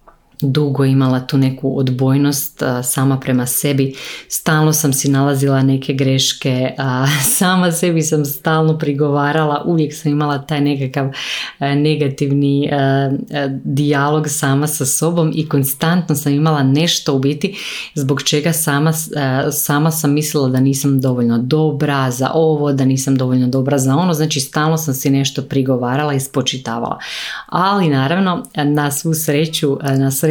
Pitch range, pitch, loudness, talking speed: 135-155 Hz, 145 Hz, -15 LUFS, 135 wpm